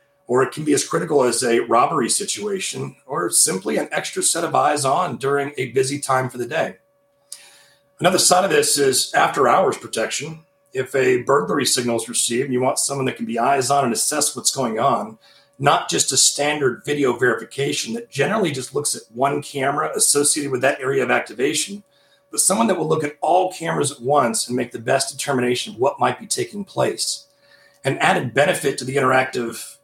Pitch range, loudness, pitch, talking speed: 130-180 Hz, -19 LUFS, 140 Hz, 200 wpm